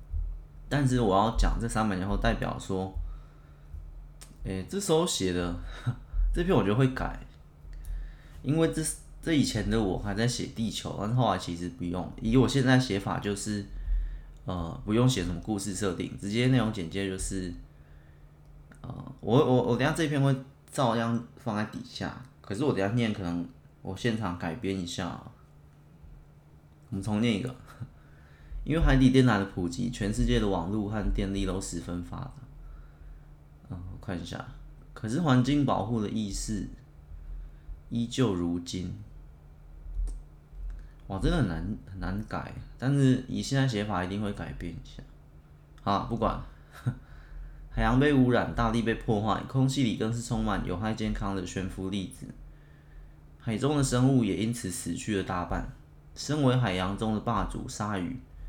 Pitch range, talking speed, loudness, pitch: 80-120 Hz, 235 characters per minute, -29 LUFS, 100 Hz